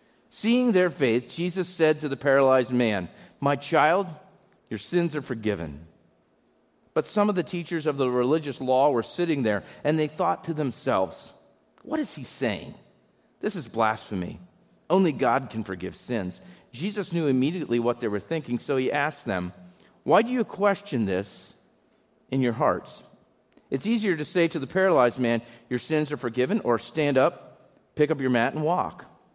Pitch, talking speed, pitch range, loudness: 140 Hz, 170 wpm, 120-170 Hz, -26 LUFS